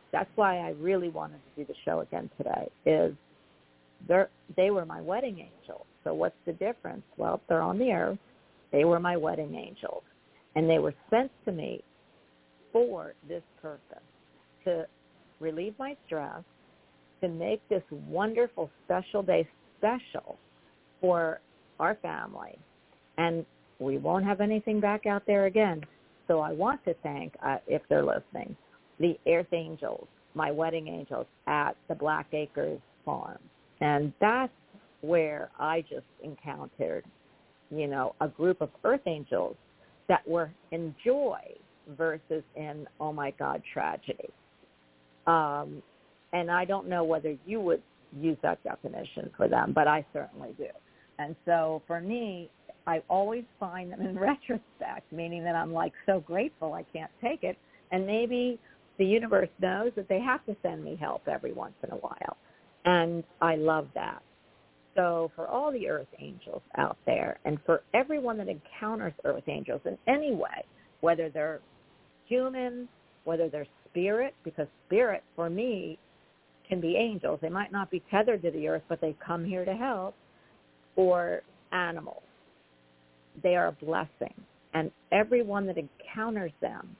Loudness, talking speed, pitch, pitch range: -31 LUFS, 155 wpm, 170 Hz, 155-205 Hz